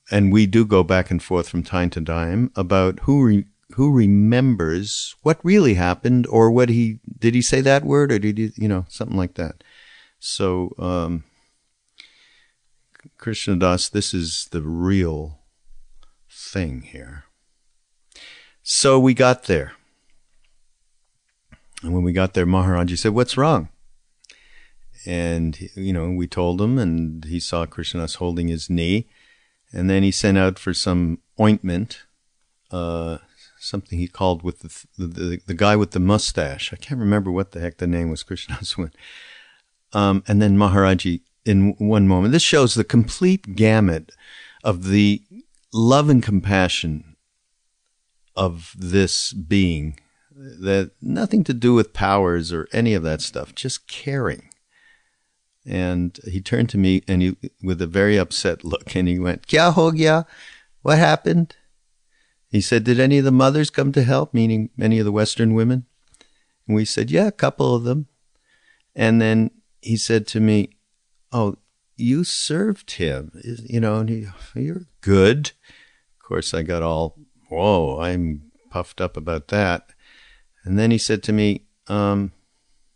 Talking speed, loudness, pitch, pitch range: 155 wpm, -20 LUFS, 100 Hz, 90-120 Hz